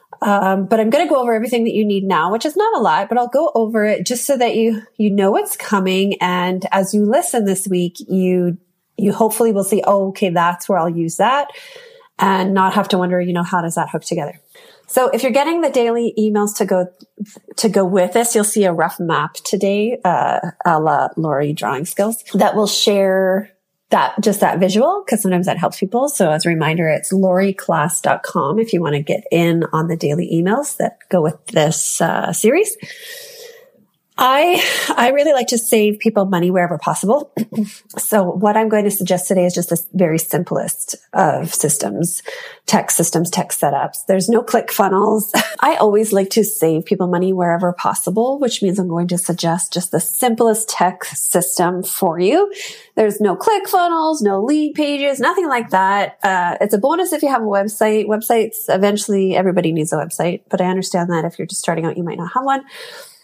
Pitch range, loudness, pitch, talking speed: 180-235 Hz, -16 LUFS, 200 Hz, 200 wpm